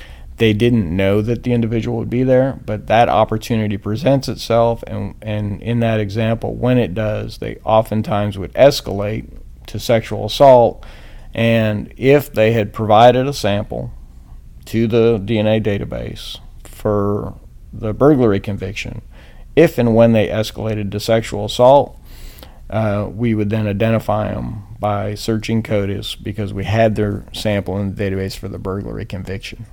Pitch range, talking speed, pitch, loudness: 100-115 Hz, 145 wpm, 105 Hz, -17 LUFS